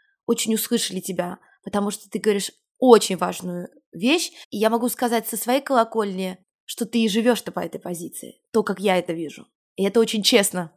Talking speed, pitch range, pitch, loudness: 185 wpm, 190-235 Hz, 220 Hz, -22 LUFS